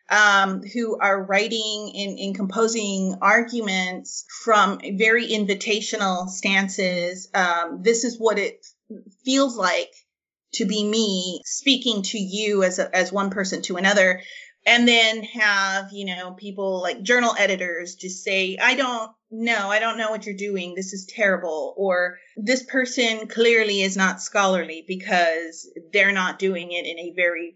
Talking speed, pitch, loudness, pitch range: 150 wpm, 200 Hz, -21 LUFS, 185-225 Hz